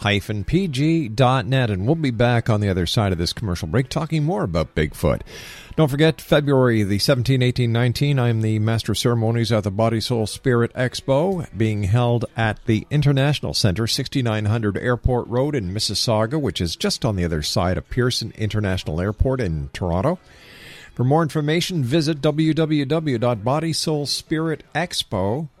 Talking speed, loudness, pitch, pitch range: 150 wpm, -21 LUFS, 120 Hz, 110-145 Hz